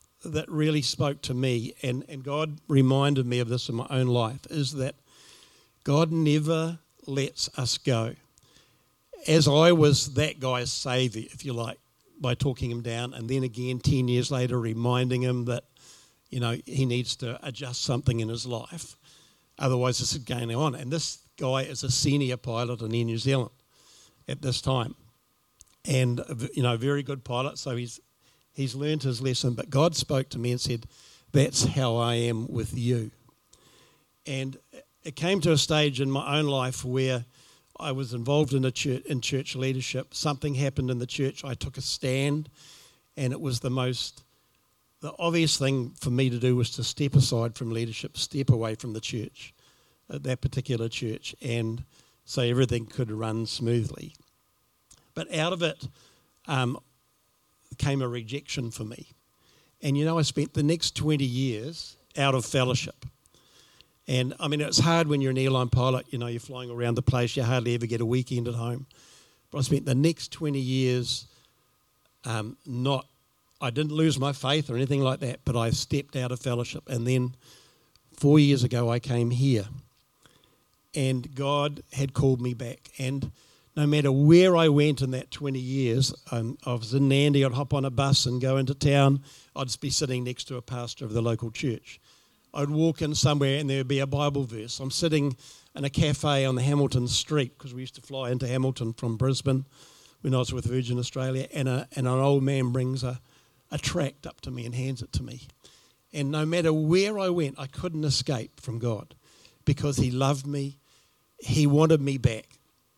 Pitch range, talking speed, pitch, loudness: 125-145 Hz, 185 wpm, 130 Hz, -27 LUFS